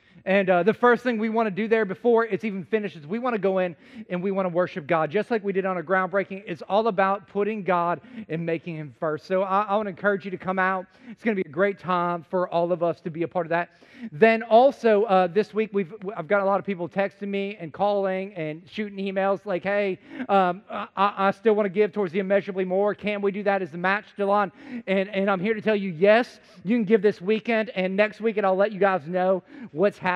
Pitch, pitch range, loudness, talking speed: 200 Hz, 185-215 Hz, -24 LUFS, 265 wpm